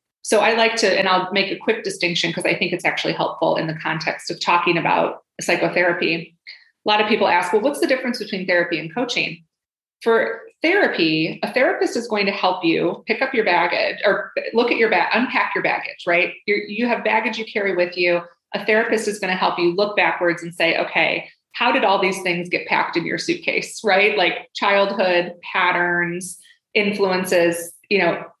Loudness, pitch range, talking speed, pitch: -19 LUFS, 175-220 Hz, 200 wpm, 190 Hz